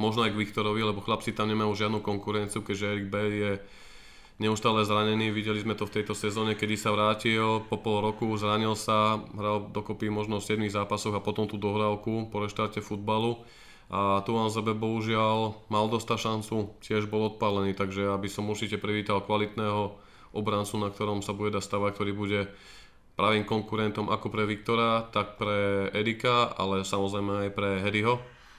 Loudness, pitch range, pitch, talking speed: -29 LUFS, 105-110 Hz, 105 Hz, 170 wpm